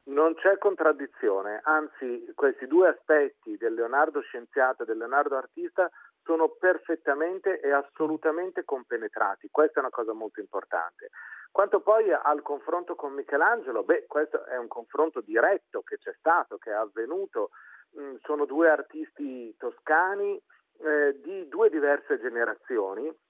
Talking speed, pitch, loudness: 130 wpm, 220 Hz, -27 LUFS